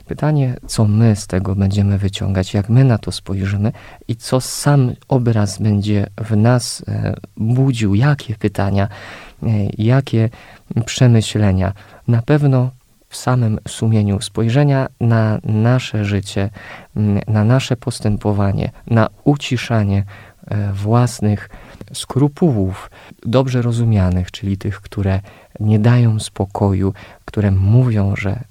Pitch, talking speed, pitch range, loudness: 110 Hz, 105 wpm, 100-125 Hz, -17 LUFS